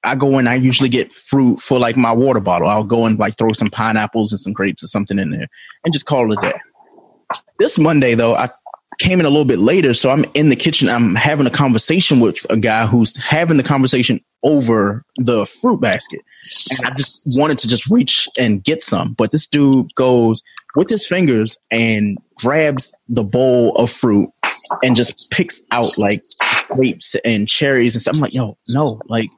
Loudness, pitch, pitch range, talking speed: -14 LUFS, 125 Hz, 115-145 Hz, 205 wpm